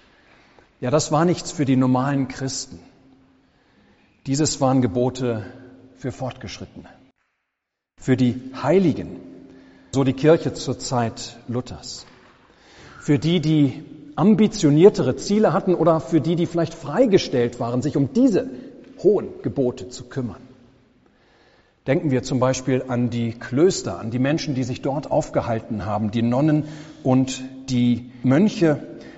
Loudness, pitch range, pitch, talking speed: -21 LUFS, 125-155 Hz, 130 Hz, 125 wpm